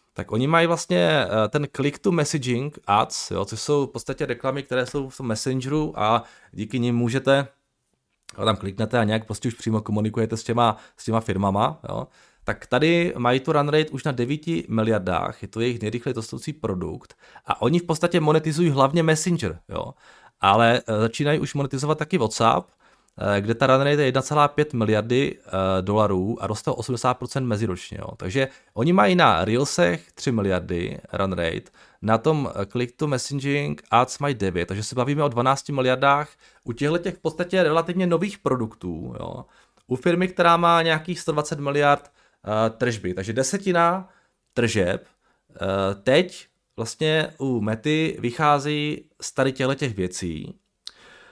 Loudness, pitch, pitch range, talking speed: -23 LUFS, 130 Hz, 110-150 Hz, 160 wpm